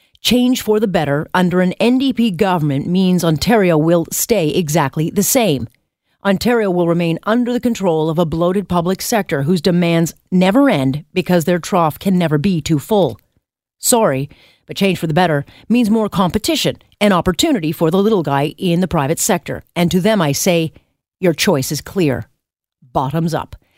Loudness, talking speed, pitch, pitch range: -16 LUFS, 170 wpm, 175 Hz, 155-200 Hz